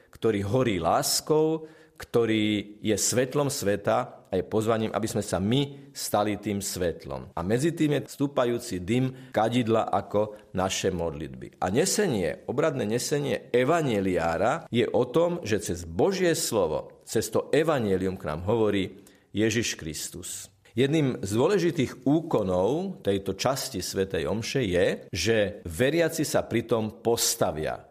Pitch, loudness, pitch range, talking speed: 110 Hz, -27 LUFS, 100-140 Hz, 130 wpm